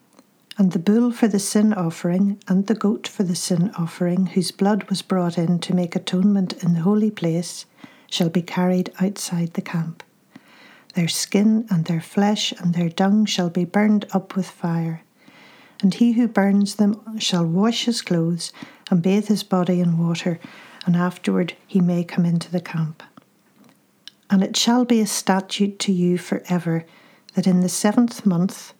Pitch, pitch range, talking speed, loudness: 190 Hz, 175-210 Hz, 175 wpm, -21 LUFS